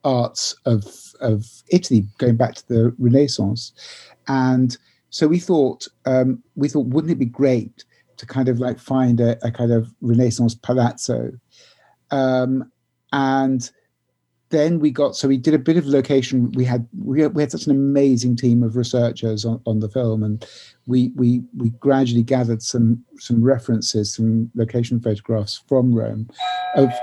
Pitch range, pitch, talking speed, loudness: 115-135 Hz, 125 Hz, 160 wpm, -19 LUFS